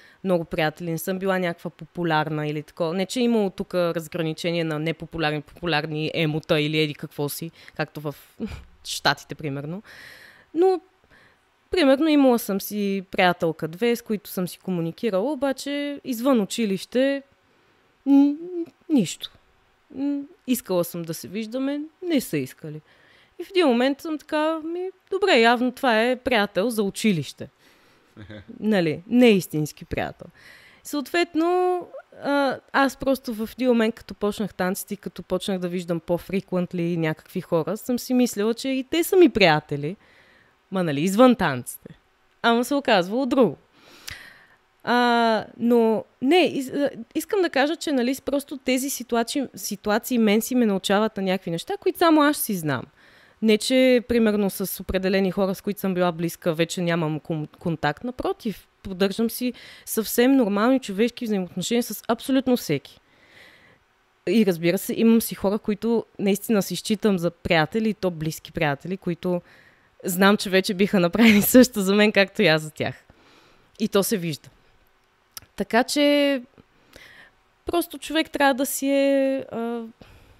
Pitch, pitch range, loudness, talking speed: 210 Hz, 175-260 Hz, -23 LUFS, 145 wpm